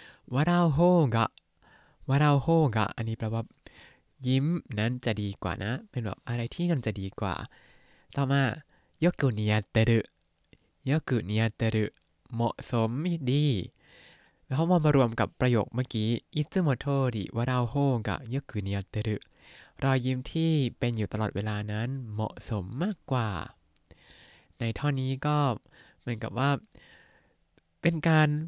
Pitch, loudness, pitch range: 120 Hz, -29 LUFS, 110-140 Hz